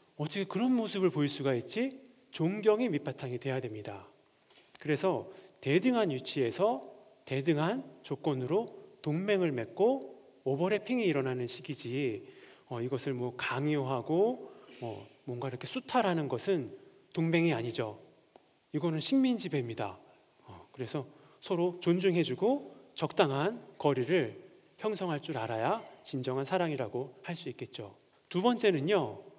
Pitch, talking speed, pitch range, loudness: 155 Hz, 285 characters per minute, 135-195 Hz, -33 LUFS